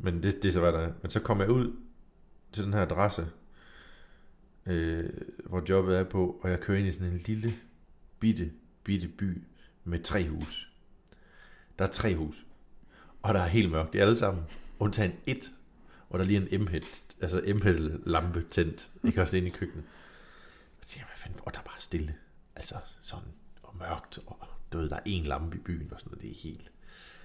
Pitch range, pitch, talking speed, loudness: 85-100 Hz, 90 Hz, 205 wpm, -31 LUFS